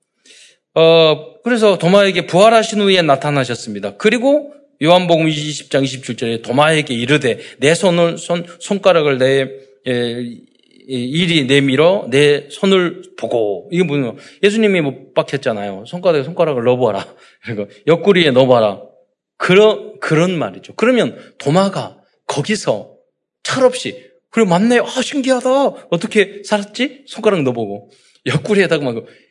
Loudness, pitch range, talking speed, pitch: -15 LUFS, 135-210 Hz, 290 characters per minute, 170 Hz